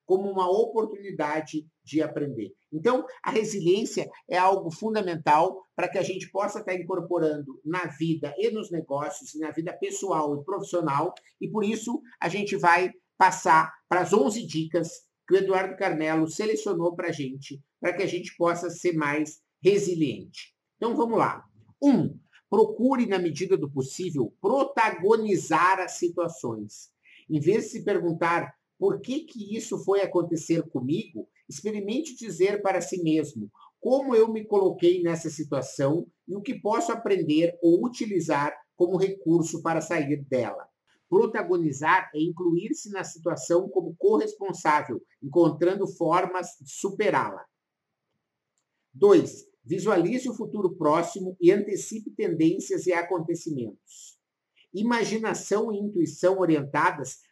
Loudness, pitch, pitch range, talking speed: -26 LUFS, 180 Hz, 160-205 Hz, 135 wpm